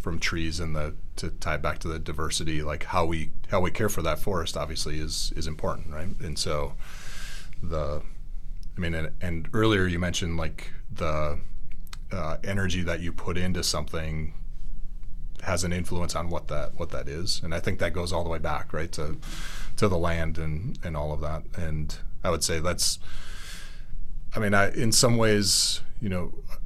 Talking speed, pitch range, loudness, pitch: 190 wpm, 75-90 Hz, -29 LUFS, 80 Hz